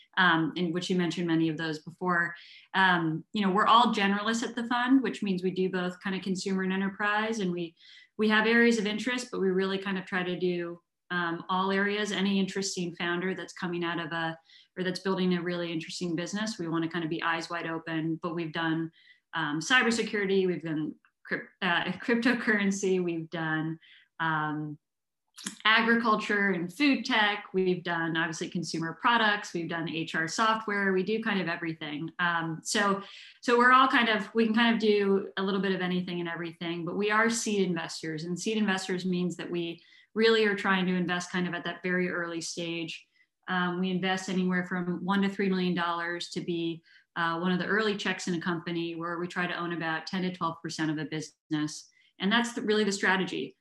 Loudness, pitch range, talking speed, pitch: -29 LUFS, 170-205 Hz, 205 wpm, 180 Hz